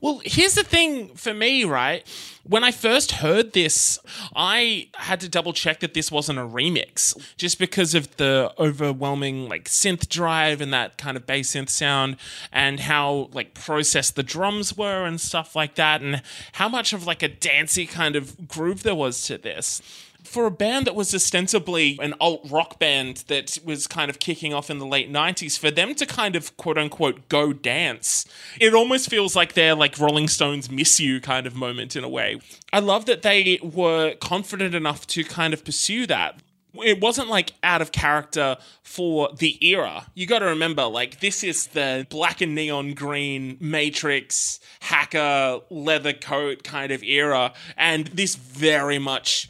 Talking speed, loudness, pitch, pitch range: 185 wpm, -21 LUFS, 155 Hz, 145-185 Hz